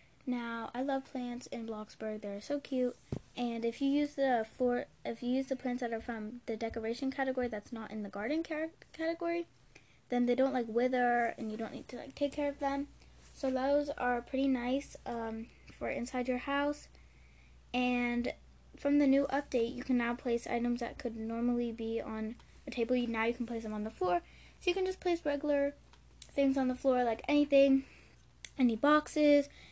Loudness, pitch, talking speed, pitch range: -34 LUFS, 250 Hz, 200 wpm, 230-280 Hz